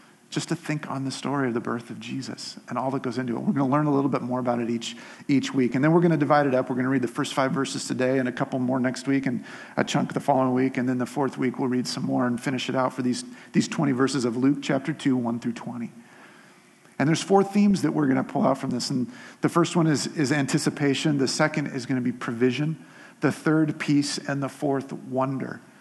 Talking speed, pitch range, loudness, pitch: 270 wpm, 130-150 Hz, -25 LUFS, 135 Hz